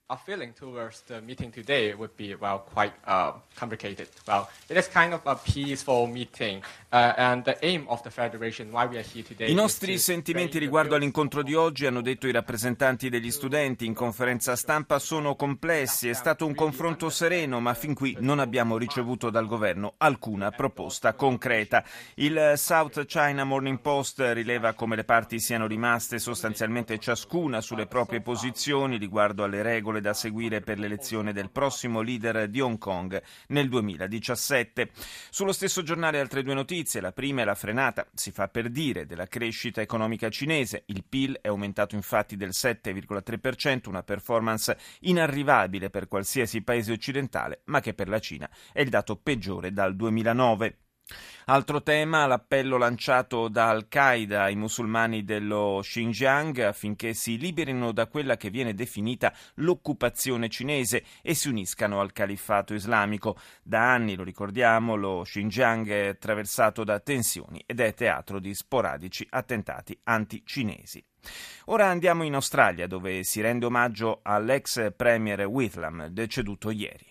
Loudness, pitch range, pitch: -27 LUFS, 105-135 Hz, 120 Hz